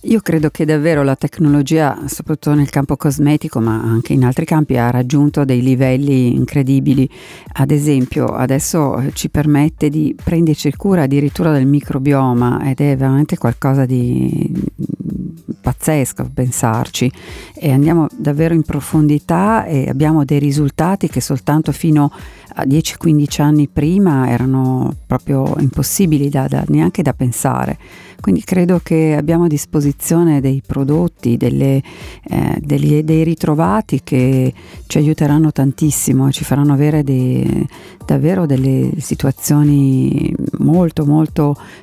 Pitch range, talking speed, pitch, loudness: 135-155 Hz, 130 wpm, 145 Hz, -14 LUFS